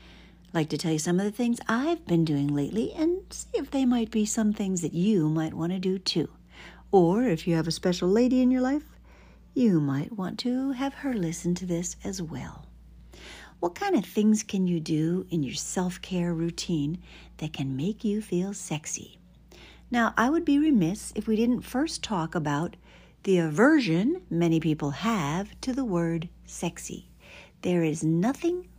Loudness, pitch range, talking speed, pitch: -27 LUFS, 165-240 Hz, 185 wpm, 185 Hz